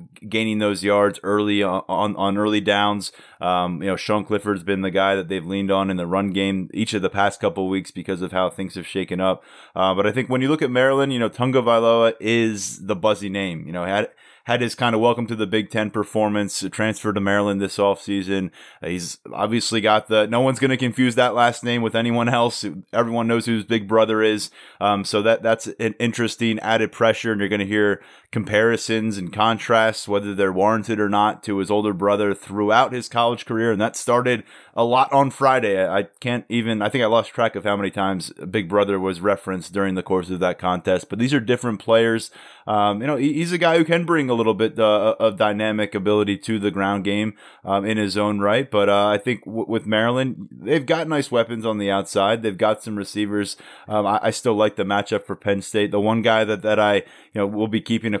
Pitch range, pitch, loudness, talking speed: 100-115 Hz, 105 Hz, -21 LUFS, 230 wpm